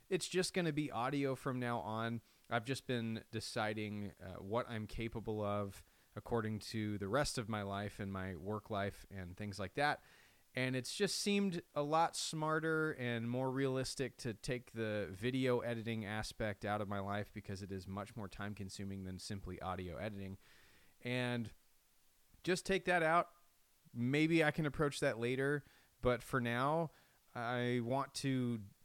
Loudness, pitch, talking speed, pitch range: -39 LUFS, 120 Hz, 170 wpm, 105-135 Hz